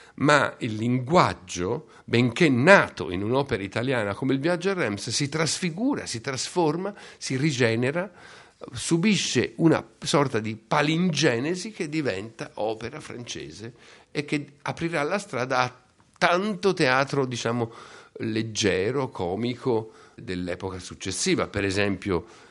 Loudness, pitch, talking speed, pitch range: -25 LUFS, 130 Hz, 115 wpm, 110-165 Hz